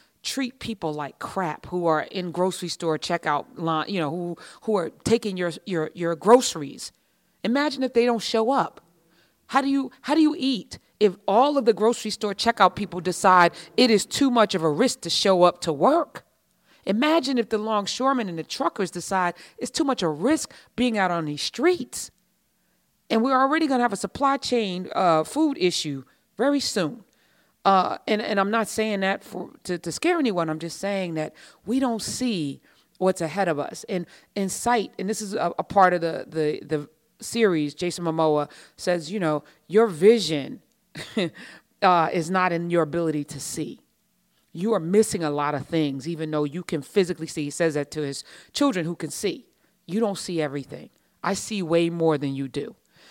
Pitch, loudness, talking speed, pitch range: 185 Hz, -24 LUFS, 195 wpm, 165-225 Hz